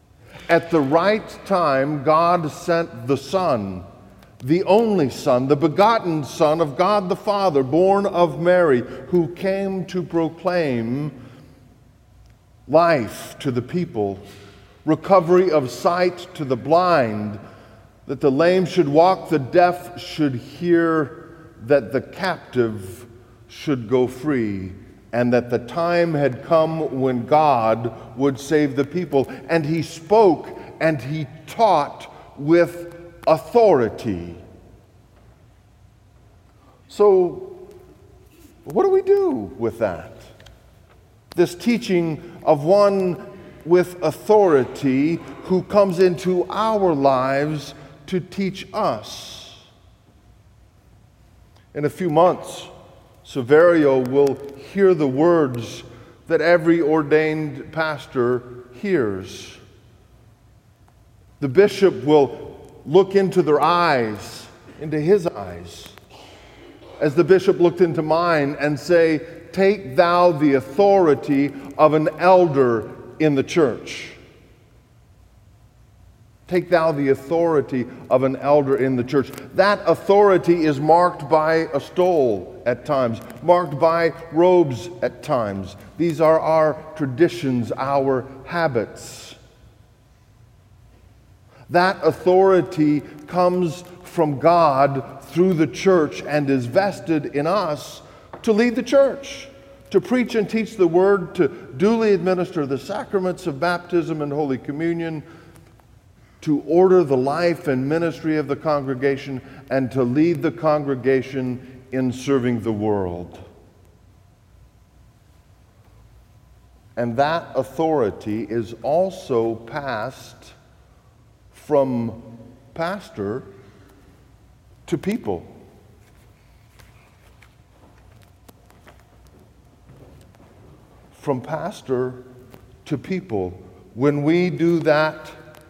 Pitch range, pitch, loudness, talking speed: 115-170 Hz, 140 Hz, -19 LUFS, 105 wpm